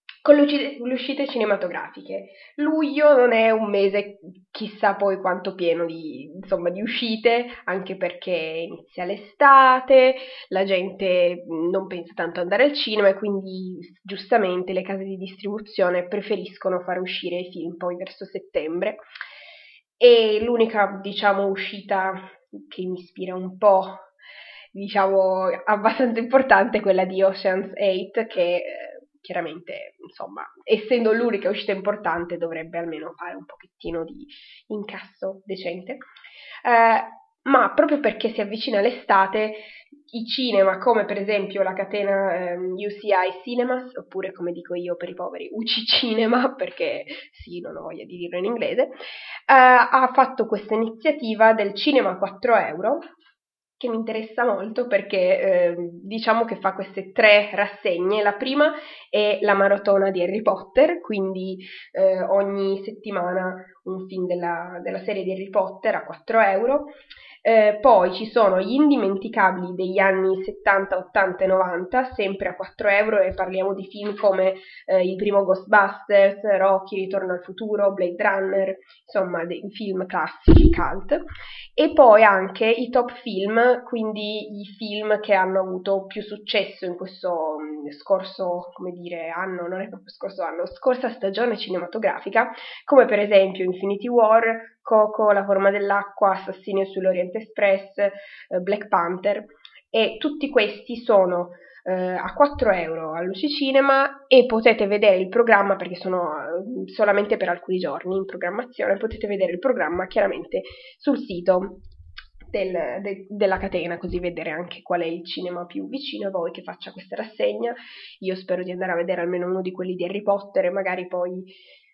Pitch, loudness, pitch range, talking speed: 200 Hz, -21 LUFS, 185-225 Hz, 150 wpm